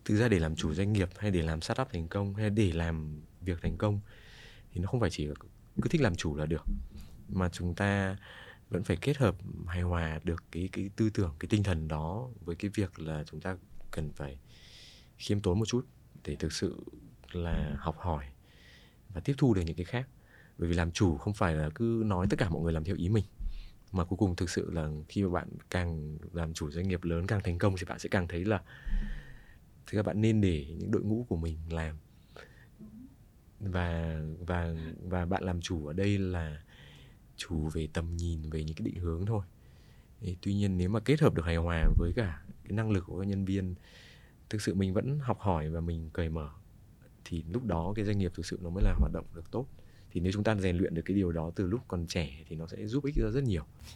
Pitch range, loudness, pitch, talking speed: 80-105 Hz, -33 LUFS, 90 Hz, 235 wpm